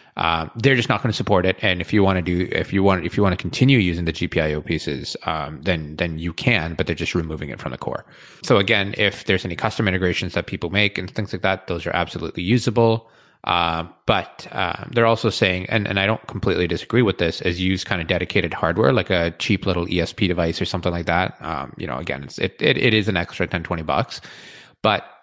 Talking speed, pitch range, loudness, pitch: 245 wpm, 85-105 Hz, -21 LUFS, 95 Hz